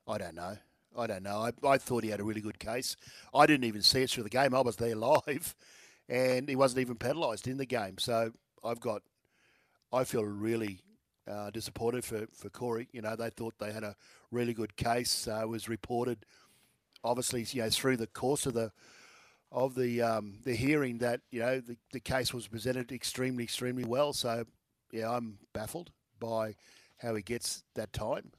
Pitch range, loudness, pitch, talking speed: 110-125 Hz, -33 LUFS, 120 Hz, 200 wpm